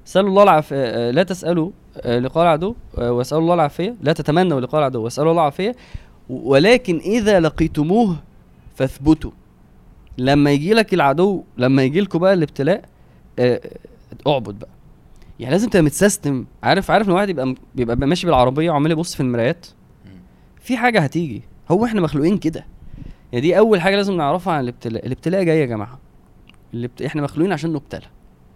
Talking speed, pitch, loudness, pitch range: 155 wpm, 155 Hz, -18 LUFS, 125-180 Hz